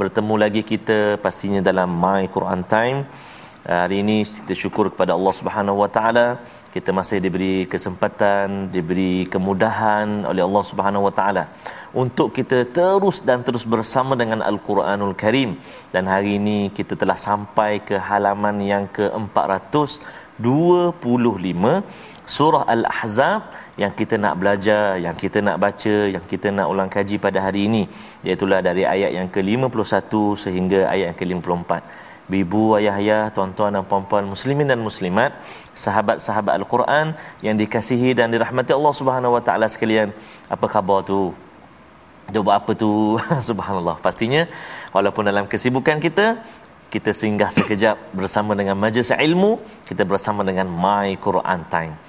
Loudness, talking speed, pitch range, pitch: -20 LUFS, 135 wpm, 100-115 Hz, 105 Hz